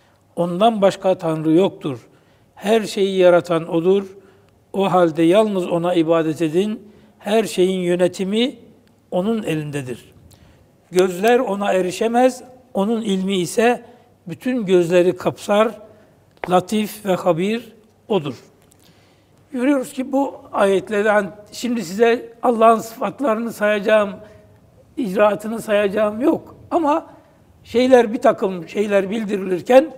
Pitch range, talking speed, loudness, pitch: 180-230 Hz, 100 wpm, -18 LUFS, 205 Hz